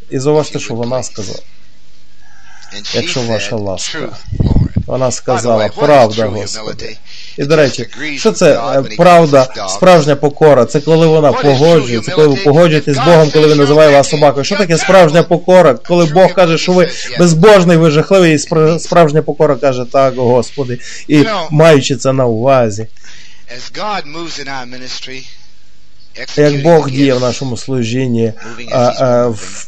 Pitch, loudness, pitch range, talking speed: 140 Hz, -10 LUFS, 125-160 Hz, 135 wpm